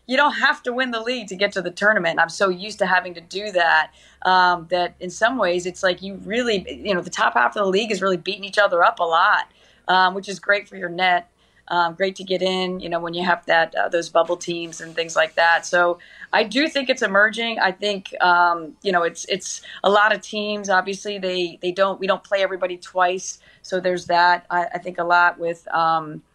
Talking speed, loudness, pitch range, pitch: 245 wpm, -20 LUFS, 175-200 Hz, 185 Hz